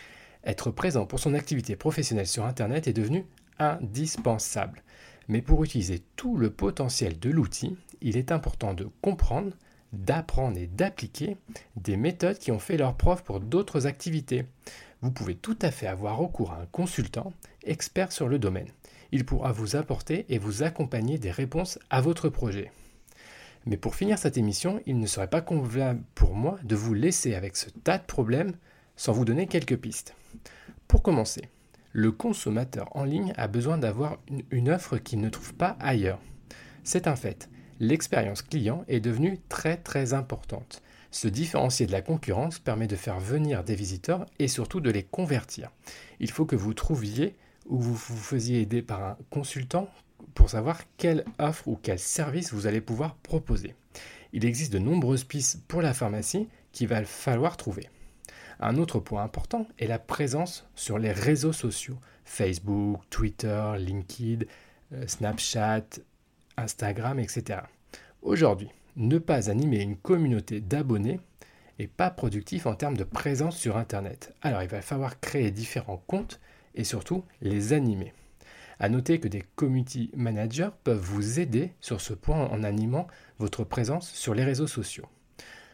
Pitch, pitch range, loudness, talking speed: 125 Hz, 110-155 Hz, -29 LUFS, 160 wpm